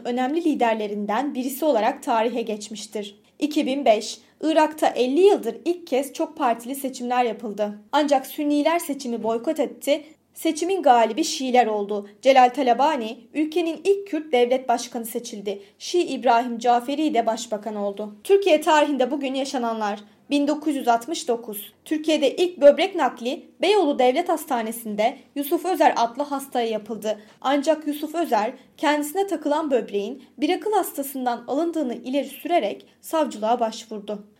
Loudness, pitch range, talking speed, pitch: -23 LUFS, 230-305 Hz, 120 wpm, 260 Hz